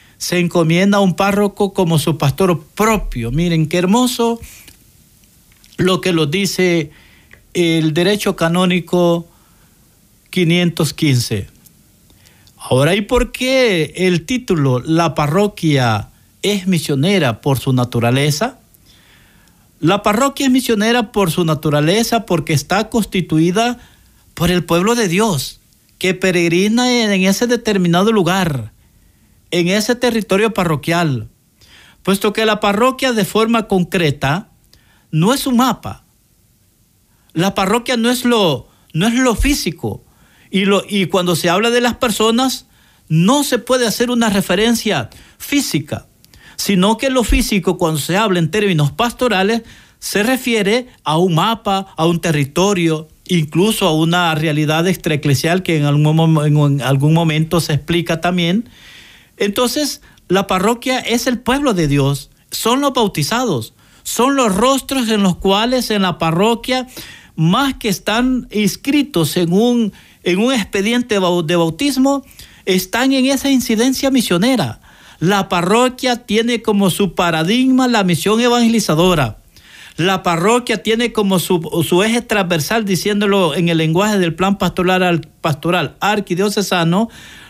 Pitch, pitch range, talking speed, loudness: 185 Hz, 160-225 Hz, 130 wpm, -15 LUFS